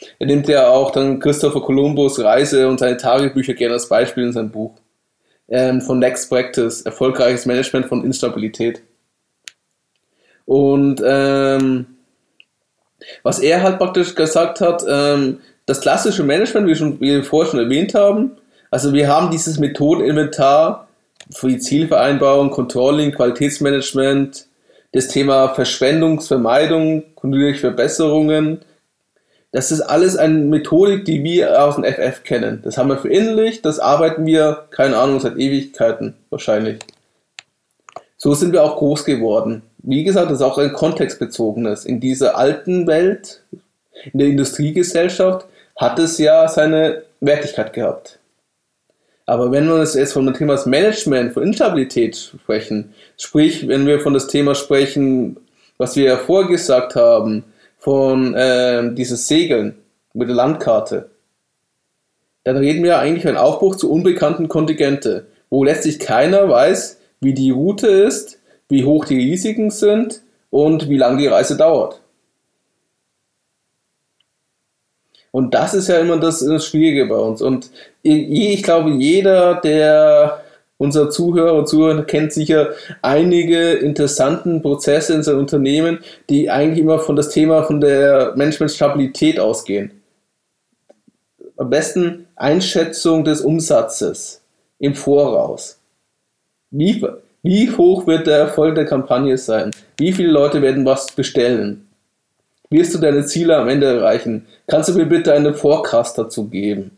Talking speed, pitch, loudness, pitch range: 135 wpm, 145 Hz, -15 LUFS, 135-160 Hz